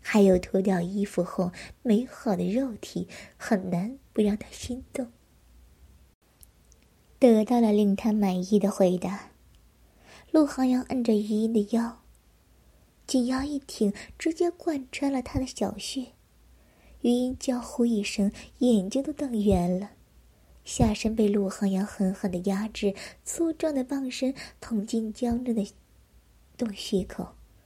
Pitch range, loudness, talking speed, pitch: 195-255 Hz, -27 LUFS, 190 characters per minute, 215 Hz